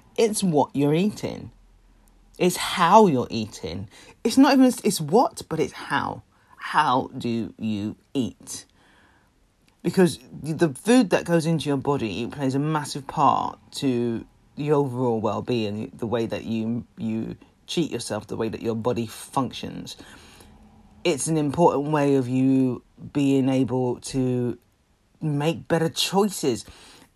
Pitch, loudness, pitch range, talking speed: 130 Hz, -24 LUFS, 115-165 Hz, 135 wpm